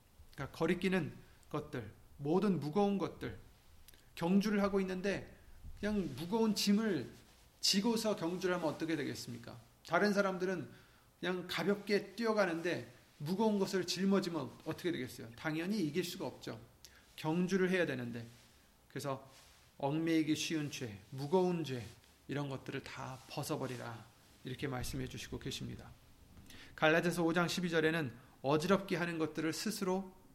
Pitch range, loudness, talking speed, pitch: 130-185 Hz, -37 LUFS, 310 characters per minute, 160 Hz